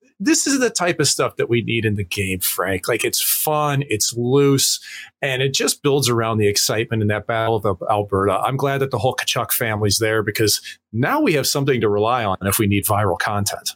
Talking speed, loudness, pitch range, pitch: 220 wpm, -19 LUFS, 105-140 Hz, 115 Hz